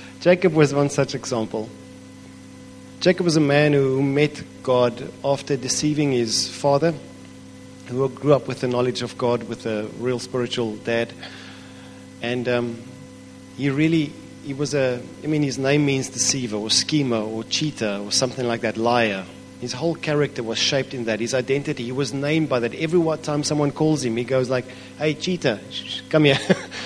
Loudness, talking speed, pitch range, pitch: -22 LUFS, 165 wpm, 120-145 Hz, 130 Hz